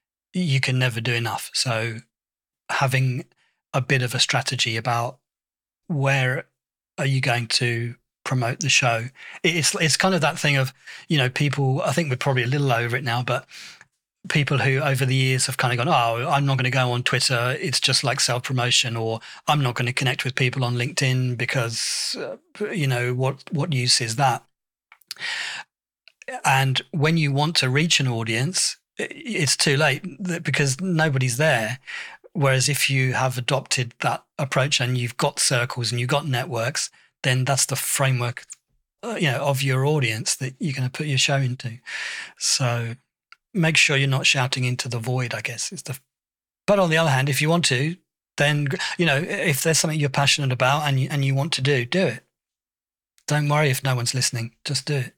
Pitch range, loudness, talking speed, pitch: 125-145 Hz, -22 LUFS, 190 wpm, 135 Hz